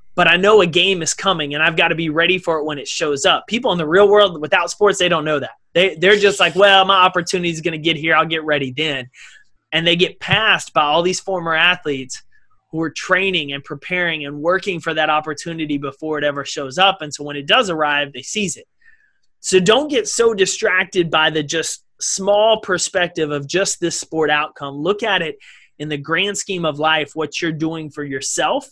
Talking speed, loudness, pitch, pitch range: 225 wpm, -16 LUFS, 170 Hz, 155-190 Hz